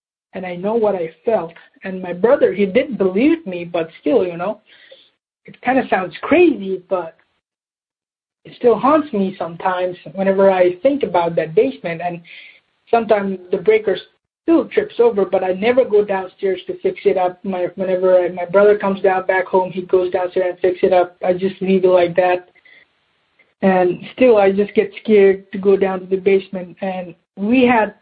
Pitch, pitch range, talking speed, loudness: 190 Hz, 180-210 Hz, 185 wpm, -17 LUFS